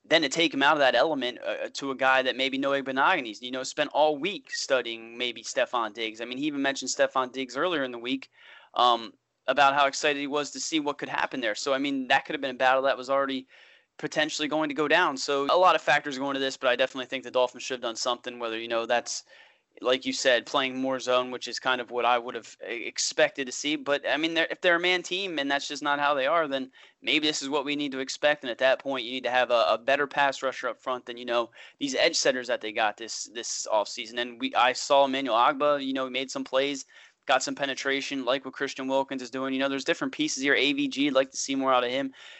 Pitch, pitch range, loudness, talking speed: 135 Hz, 130-145 Hz, -26 LUFS, 275 wpm